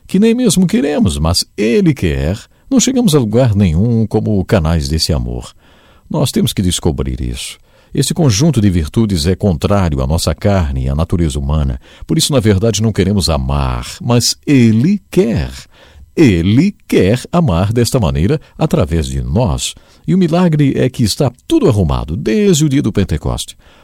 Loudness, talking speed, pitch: -13 LUFS, 165 wpm, 105 Hz